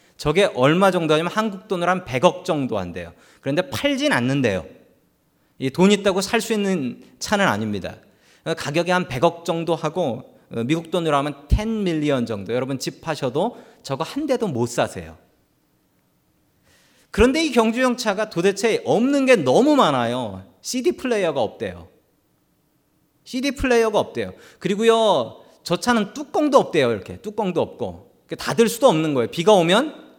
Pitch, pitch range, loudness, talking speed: 180 Hz, 145-230 Hz, -20 LUFS, 310 characters per minute